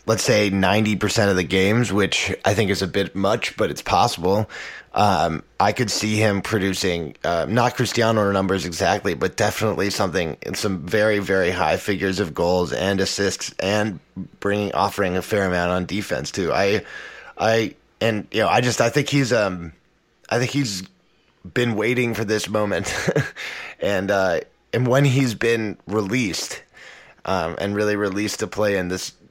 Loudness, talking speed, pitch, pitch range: -21 LUFS, 170 wpm, 100 Hz, 95-110 Hz